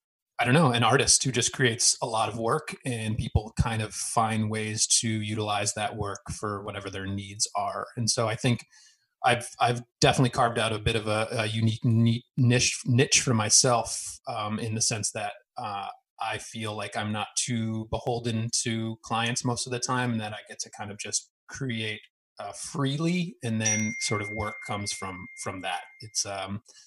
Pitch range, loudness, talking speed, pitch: 110-125 Hz, -27 LUFS, 195 wpm, 115 Hz